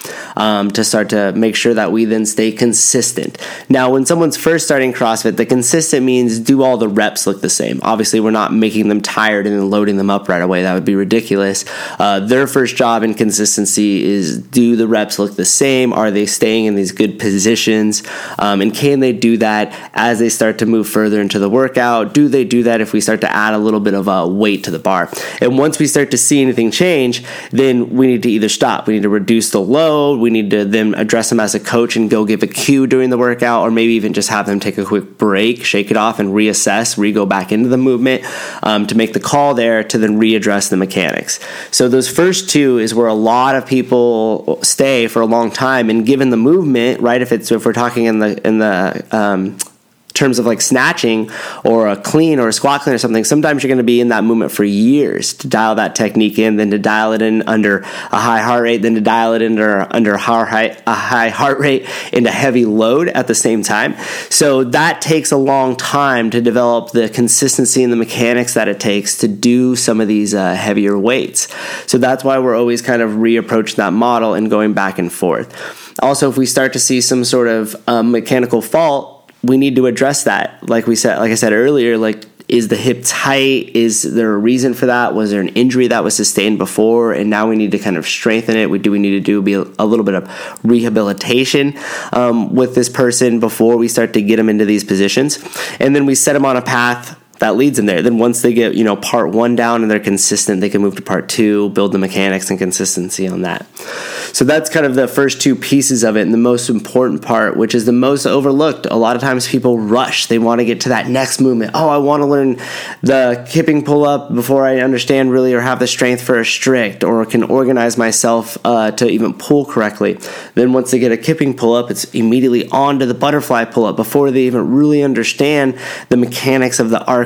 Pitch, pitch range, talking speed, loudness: 115 Hz, 105-130 Hz, 230 wpm, -13 LUFS